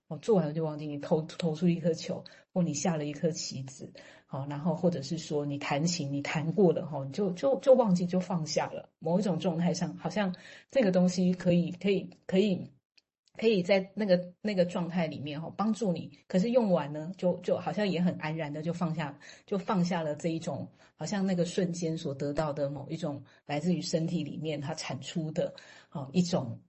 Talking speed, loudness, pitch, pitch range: 290 characters per minute, -31 LUFS, 170 Hz, 155-185 Hz